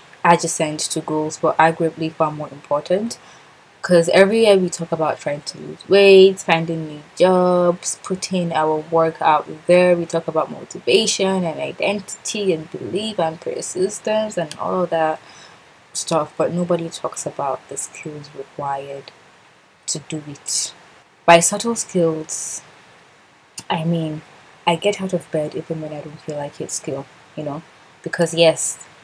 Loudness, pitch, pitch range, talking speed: -19 LUFS, 165 Hz, 155-180 Hz, 150 wpm